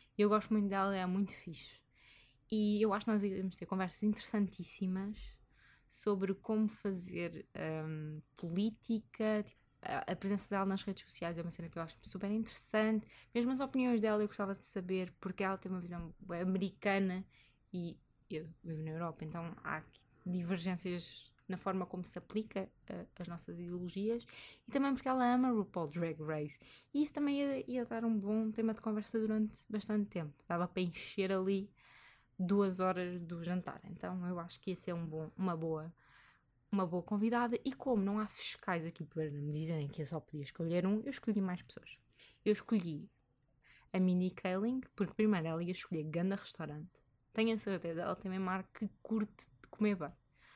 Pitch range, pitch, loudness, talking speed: 170-215 Hz, 190 Hz, -38 LUFS, 185 wpm